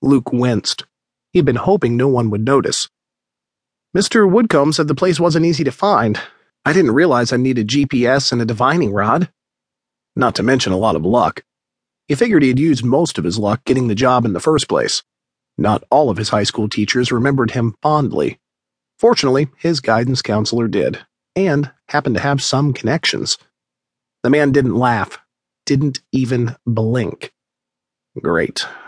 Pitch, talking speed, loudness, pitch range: 125 Hz, 165 wpm, -16 LUFS, 105-140 Hz